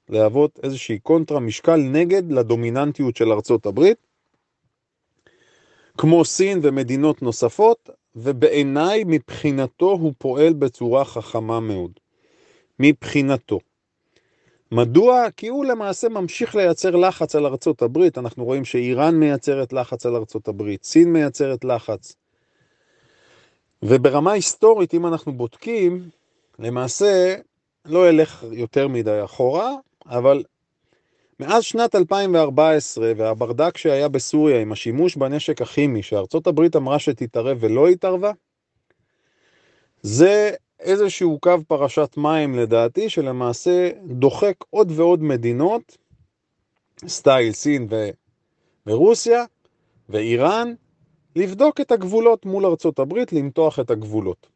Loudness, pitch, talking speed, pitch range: -19 LUFS, 150 Hz, 105 wpm, 125-180 Hz